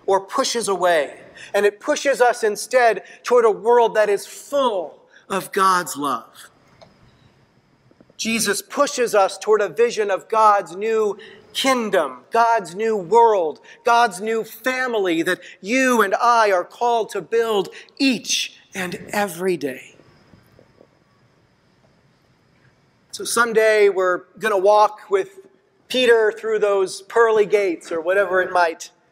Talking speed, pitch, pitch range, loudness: 125 wpm, 220 Hz, 195-240 Hz, -19 LUFS